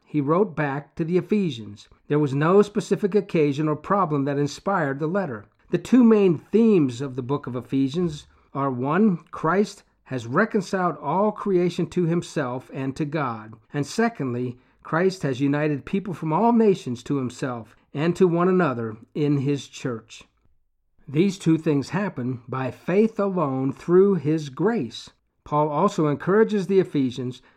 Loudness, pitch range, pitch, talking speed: -23 LUFS, 135-190 Hz, 155 Hz, 155 wpm